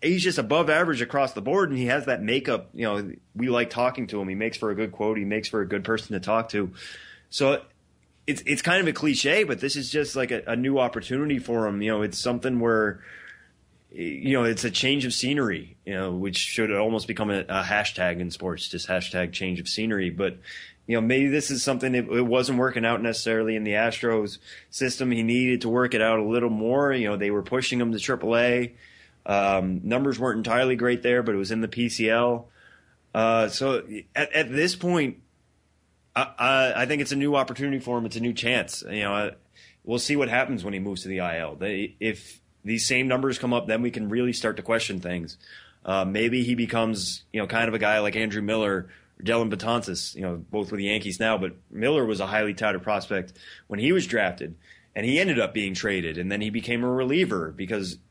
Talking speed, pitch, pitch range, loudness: 225 wpm, 115 Hz, 100-125 Hz, -25 LUFS